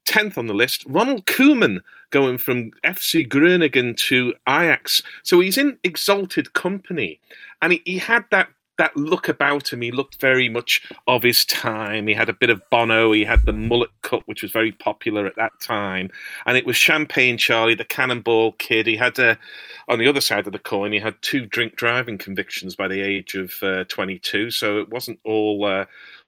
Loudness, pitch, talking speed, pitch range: -19 LUFS, 120 Hz, 195 wpm, 110-155 Hz